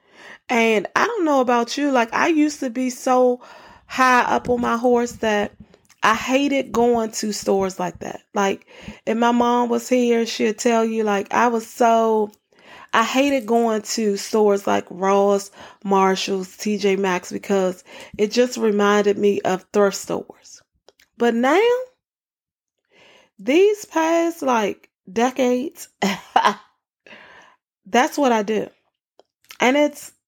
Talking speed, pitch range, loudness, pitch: 135 wpm, 205-260 Hz, -20 LUFS, 235 Hz